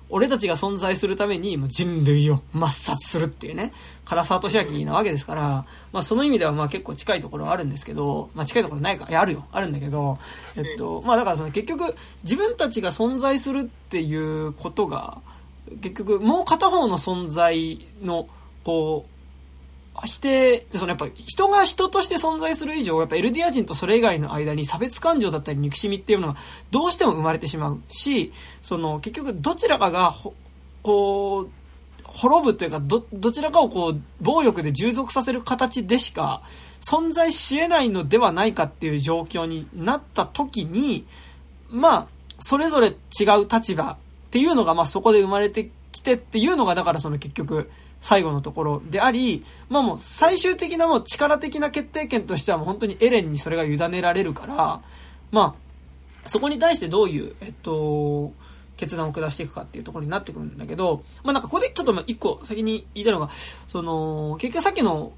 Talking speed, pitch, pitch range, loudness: 370 characters per minute, 185 Hz, 150-250 Hz, -22 LUFS